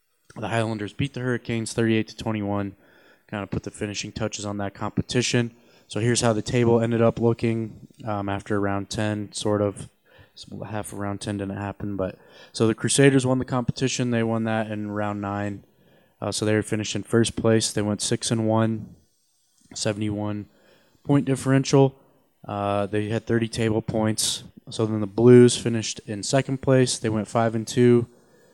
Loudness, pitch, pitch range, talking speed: -24 LUFS, 110 Hz, 105-120 Hz, 180 wpm